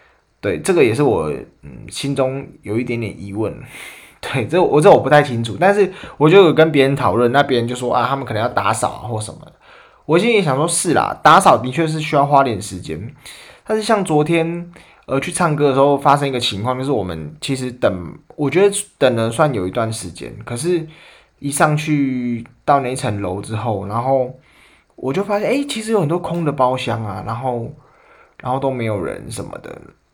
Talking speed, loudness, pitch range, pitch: 290 characters per minute, -17 LUFS, 115-155 Hz, 130 Hz